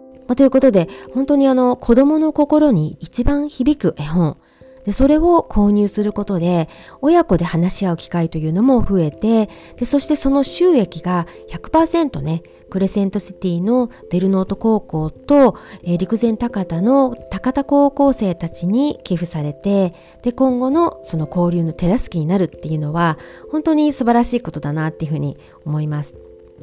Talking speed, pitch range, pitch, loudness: 320 characters per minute, 170-265 Hz, 200 Hz, -17 LUFS